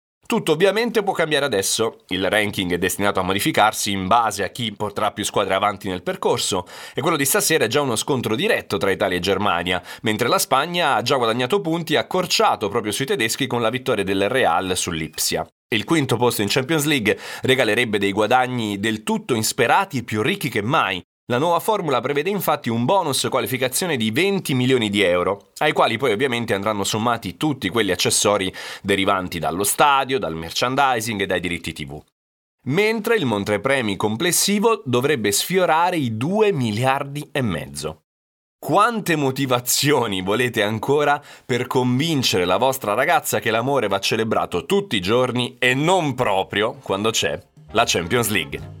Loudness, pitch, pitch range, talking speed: -20 LUFS, 120 Hz, 100-145 Hz, 165 wpm